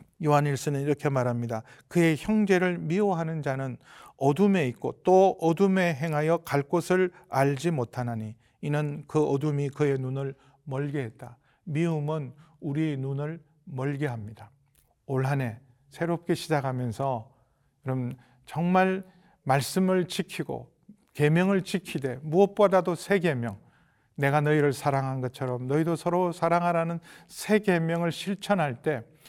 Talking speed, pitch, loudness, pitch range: 275 characters per minute, 150 Hz, -27 LUFS, 135-175 Hz